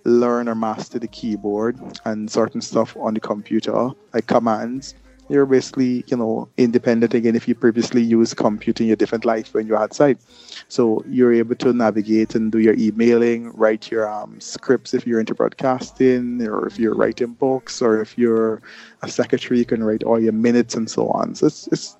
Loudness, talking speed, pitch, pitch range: -19 LUFS, 190 wpm, 115 Hz, 110-120 Hz